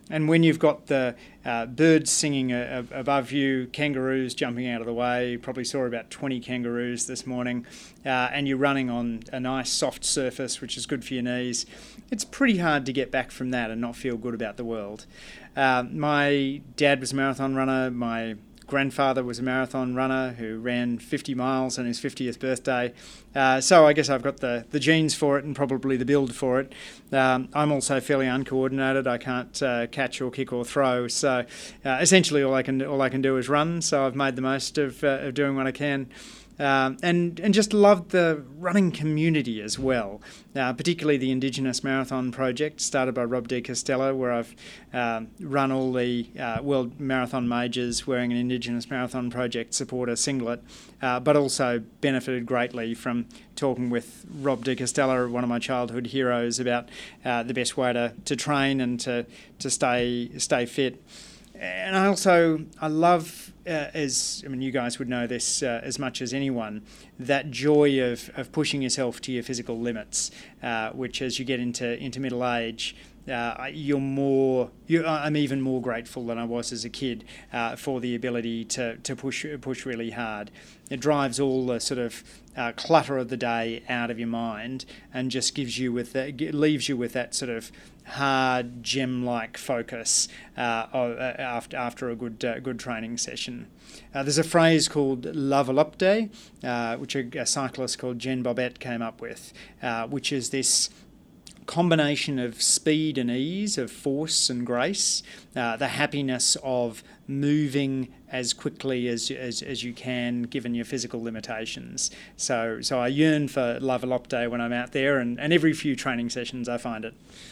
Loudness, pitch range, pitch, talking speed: -26 LUFS, 120-140 Hz, 130 Hz, 185 wpm